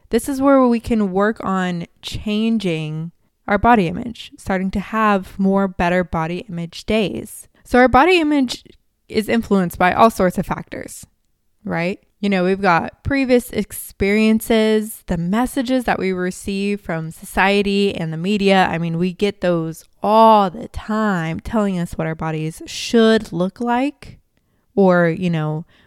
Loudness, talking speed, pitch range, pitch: -18 LUFS, 155 wpm, 180-220 Hz, 200 Hz